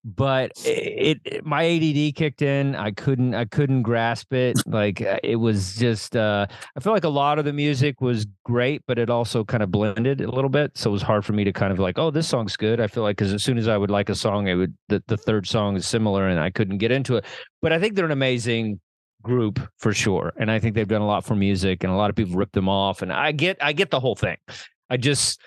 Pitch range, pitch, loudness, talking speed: 105-135 Hz, 115 Hz, -22 LUFS, 265 wpm